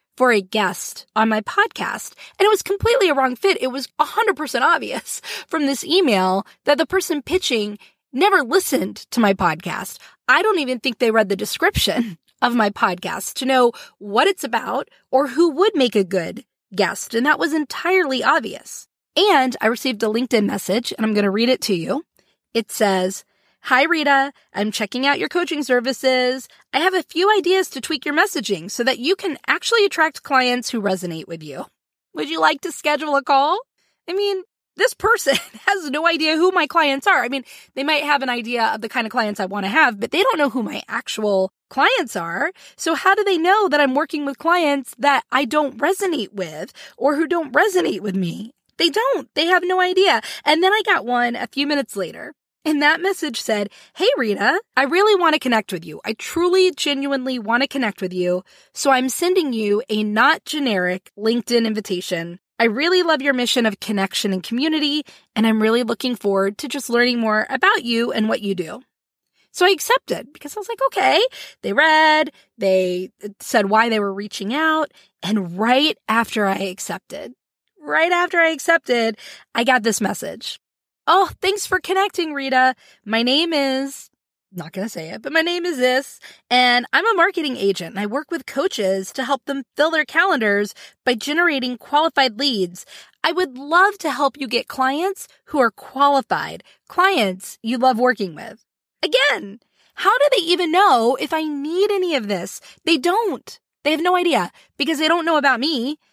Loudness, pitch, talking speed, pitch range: -19 LUFS, 270 Hz, 195 wpm, 220-330 Hz